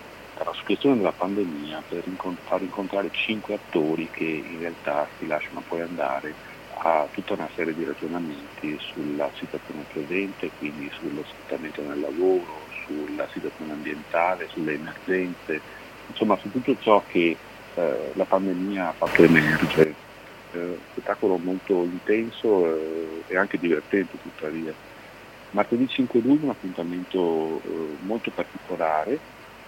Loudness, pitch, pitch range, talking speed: -26 LUFS, 90 Hz, 80-100 Hz, 125 wpm